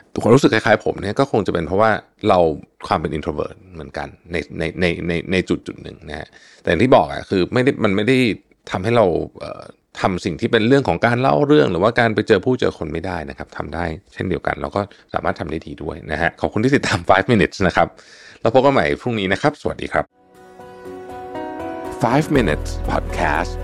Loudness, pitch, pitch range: -18 LUFS, 95 Hz, 80-125 Hz